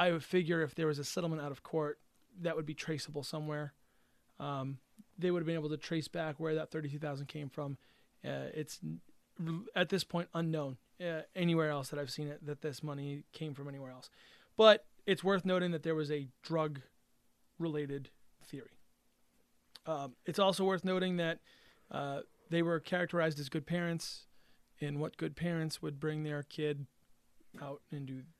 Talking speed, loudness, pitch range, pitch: 180 wpm, -37 LUFS, 145-170 Hz, 155 Hz